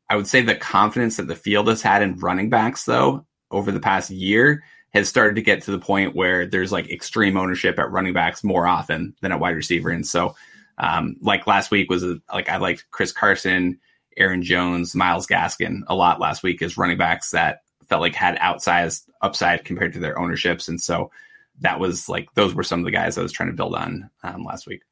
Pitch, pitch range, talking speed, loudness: 95 Hz, 90-105 Hz, 225 wpm, -20 LUFS